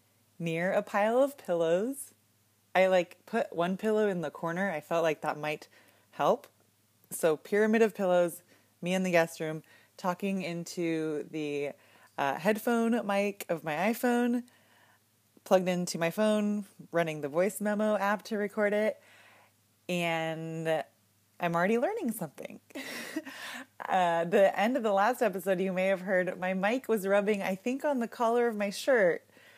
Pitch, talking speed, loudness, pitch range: 190 Hz, 155 wpm, -30 LUFS, 165-215 Hz